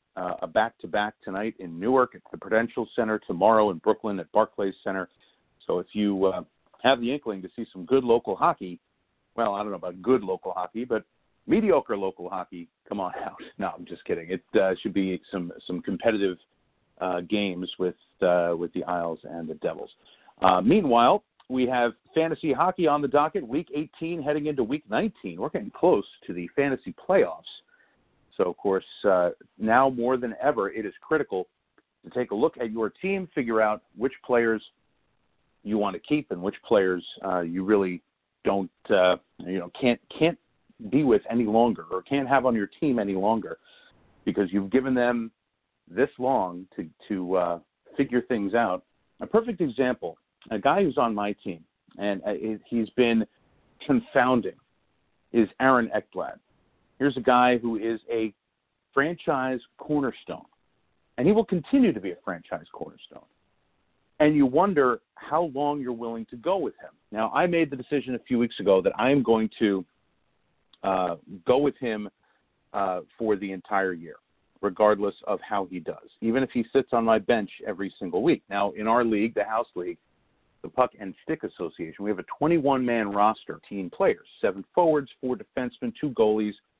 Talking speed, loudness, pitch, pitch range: 175 wpm, -26 LUFS, 115 Hz, 100-130 Hz